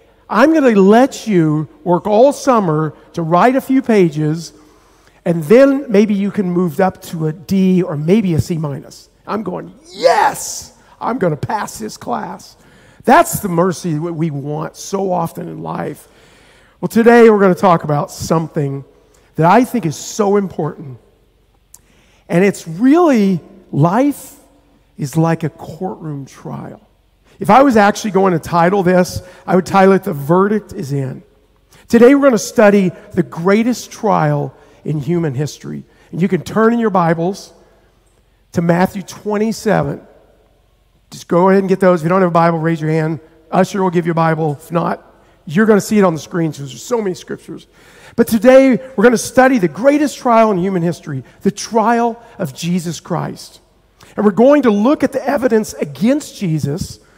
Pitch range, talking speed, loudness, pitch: 165-215 Hz, 180 wpm, -14 LUFS, 185 Hz